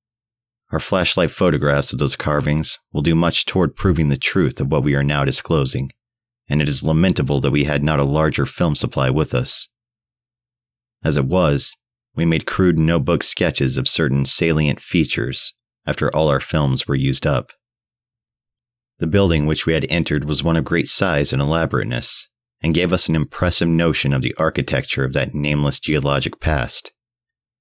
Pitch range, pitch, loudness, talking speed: 70-100 Hz, 80 Hz, -18 LUFS, 170 wpm